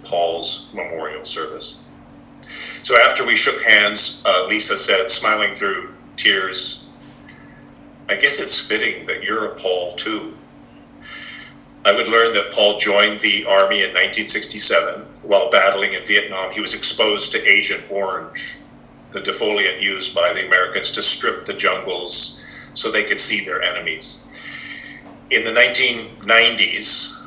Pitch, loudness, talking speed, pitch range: 100 Hz, -12 LUFS, 135 wpm, 90-105 Hz